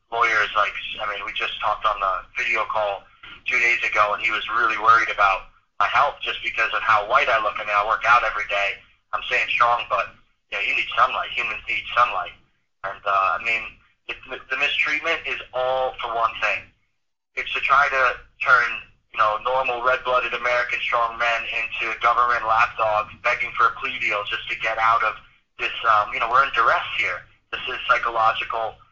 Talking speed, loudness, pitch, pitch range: 195 wpm, -21 LUFS, 115 Hz, 105-125 Hz